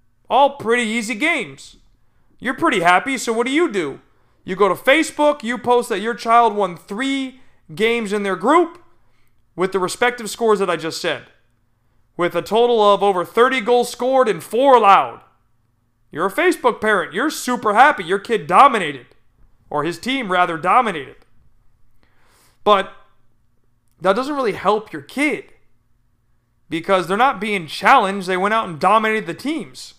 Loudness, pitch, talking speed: -17 LUFS, 200 Hz, 160 wpm